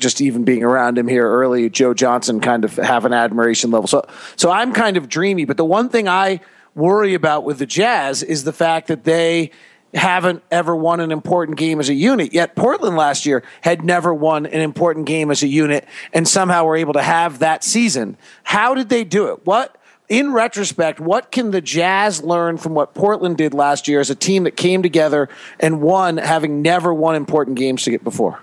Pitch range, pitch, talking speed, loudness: 145-180 Hz, 160 Hz, 215 wpm, -16 LUFS